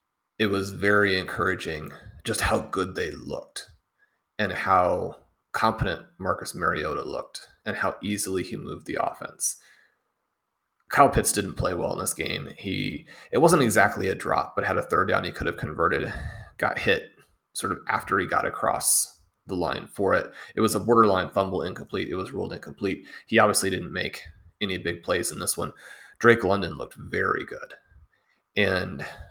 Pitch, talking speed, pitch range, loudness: 100 Hz, 170 wpm, 90-105 Hz, -26 LUFS